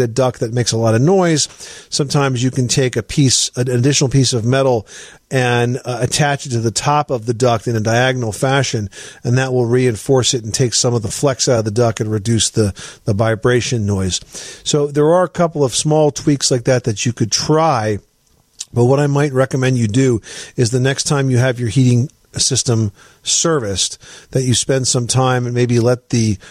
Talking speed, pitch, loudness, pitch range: 215 wpm, 125 Hz, -15 LUFS, 115-135 Hz